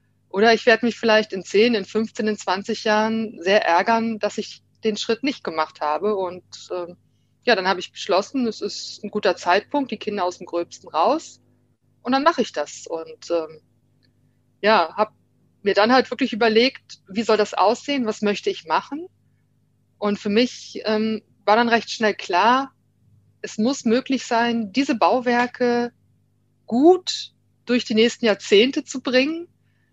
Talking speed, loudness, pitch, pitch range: 165 wpm, -21 LUFS, 220 Hz, 200-240 Hz